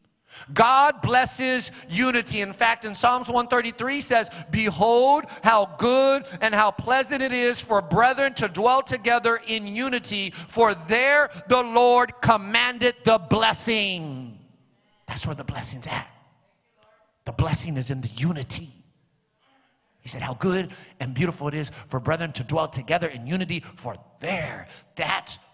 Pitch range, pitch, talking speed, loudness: 170-245 Hz, 220 Hz, 140 wpm, -22 LUFS